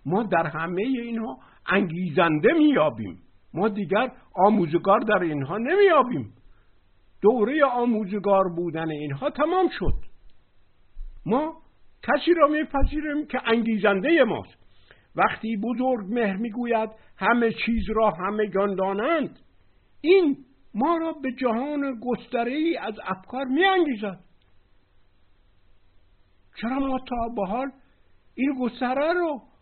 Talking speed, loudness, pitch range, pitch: 105 wpm, -24 LUFS, 165-260 Hz, 220 Hz